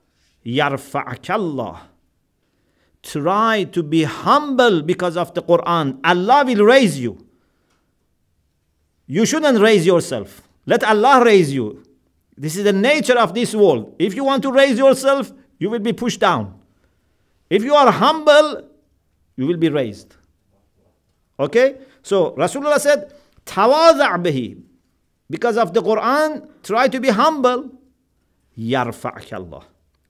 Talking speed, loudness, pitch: 120 wpm, -16 LUFS, 180 Hz